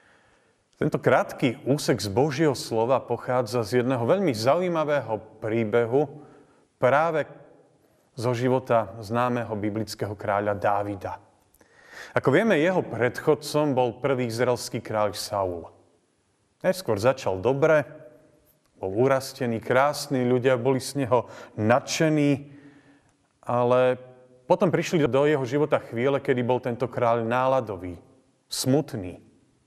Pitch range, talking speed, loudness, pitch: 115-140 Hz, 105 wpm, -25 LUFS, 125 Hz